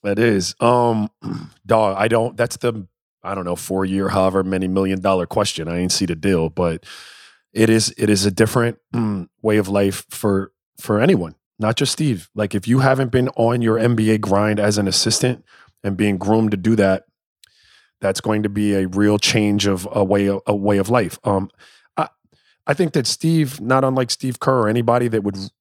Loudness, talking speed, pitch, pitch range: -19 LUFS, 200 wpm, 105 Hz, 95-120 Hz